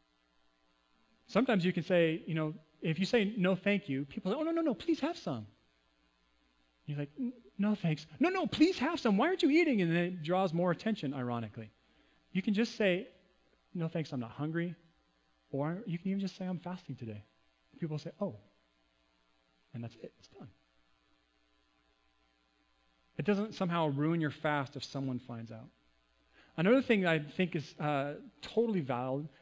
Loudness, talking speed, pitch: -34 LUFS, 180 wpm, 150 Hz